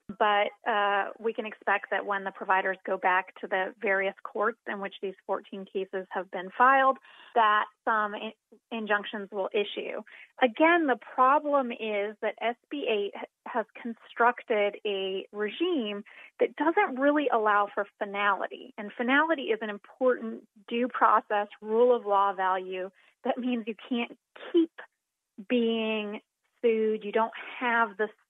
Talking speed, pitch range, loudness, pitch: 140 wpm, 205-245 Hz, -28 LUFS, 220 Hz